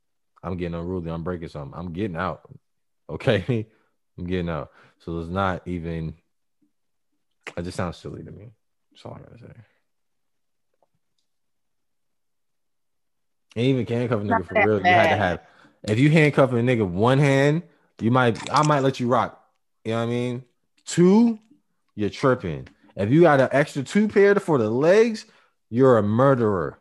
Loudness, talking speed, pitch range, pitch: -21 LUFS, 170 wpm, 95-140 Hz, 115 Hz